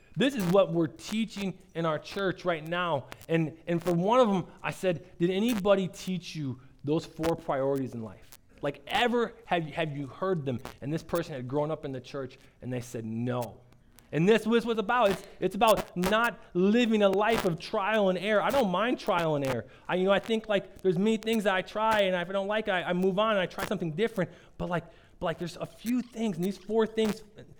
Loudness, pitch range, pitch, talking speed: -29 LUFS, 155-210 Hz, 180 Hz, 235 wpm